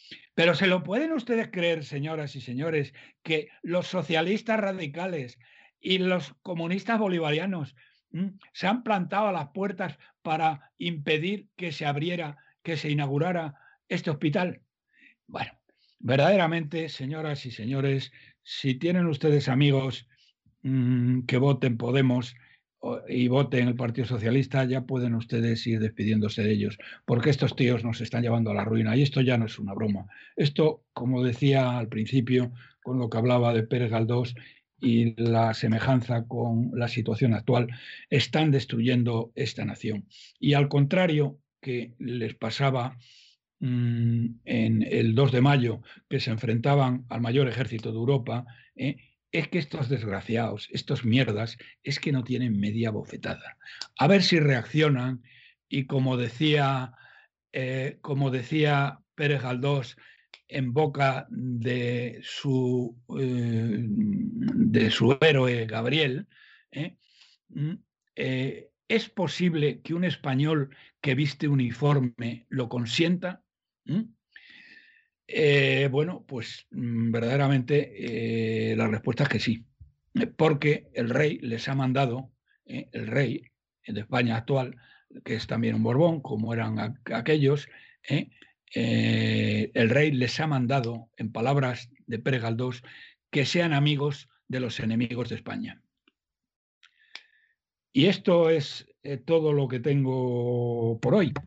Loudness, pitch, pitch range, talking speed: -27 LUFS, 130 Hz, 120-155 Hz, 130 wpm